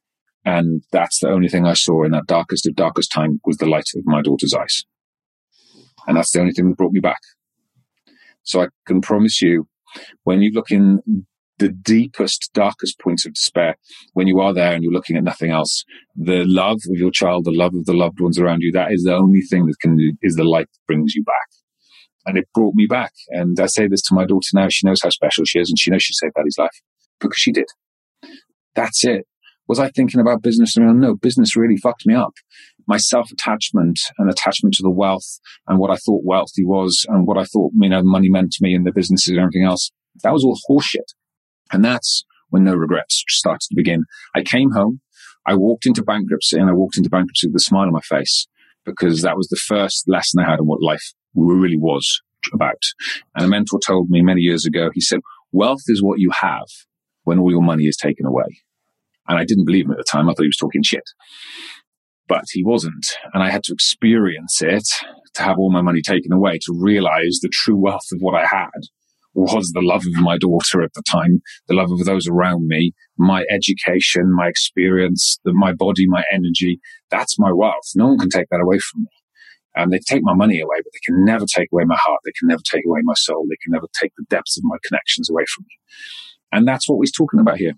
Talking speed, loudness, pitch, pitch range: 230 wpm, -16 LUFS, 90 Hz, 85-100 Hz